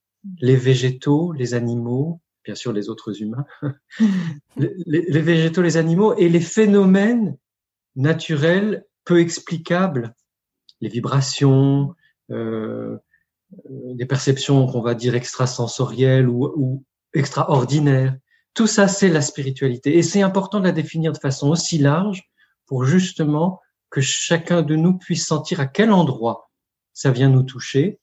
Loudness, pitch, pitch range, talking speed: -19 LUFS, 145 Hz, 130-170 Hz, 135 wpm